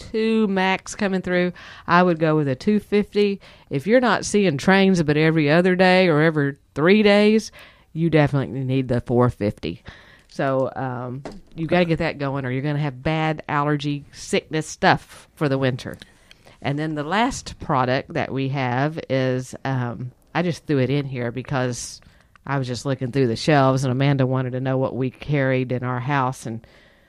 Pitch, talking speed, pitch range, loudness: 140 Hz, 185 wpm, 130-165 Hz, -21 LUFS